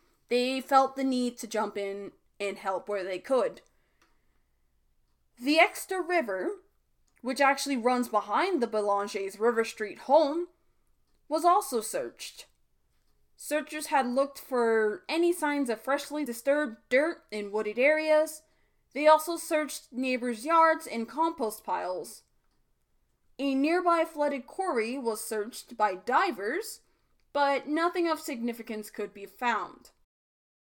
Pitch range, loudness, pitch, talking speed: 225-310 Hz, -29 LUFS, 270 Hz, 125 wpm